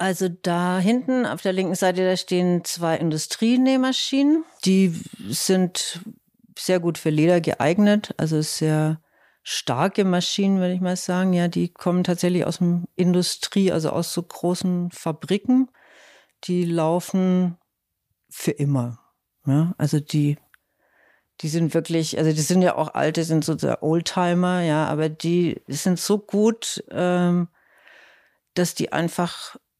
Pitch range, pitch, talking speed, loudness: 160-185 Hz, 175 Hz, 135 wpm, -22 LUFS